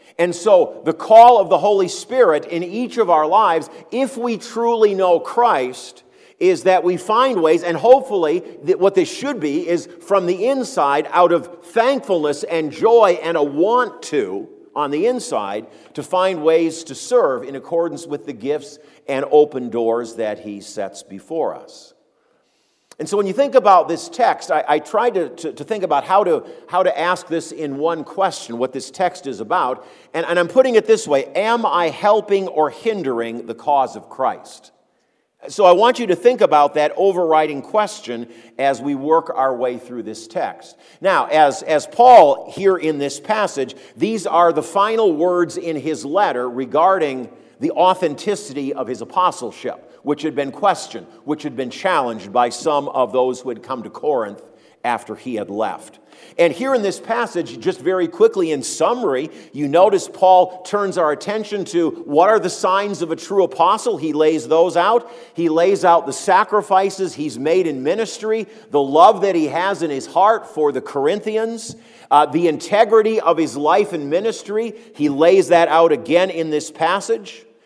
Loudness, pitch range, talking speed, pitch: -17 LUFS, 150-220 Hz, 180 wpm, 175 Hz